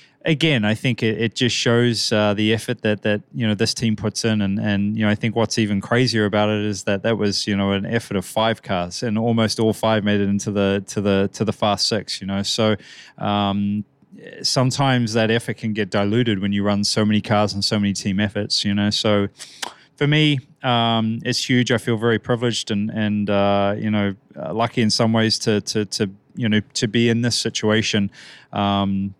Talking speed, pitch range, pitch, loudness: 220 wpm, 100-115 Hz, 110 Hz, -20 LUFS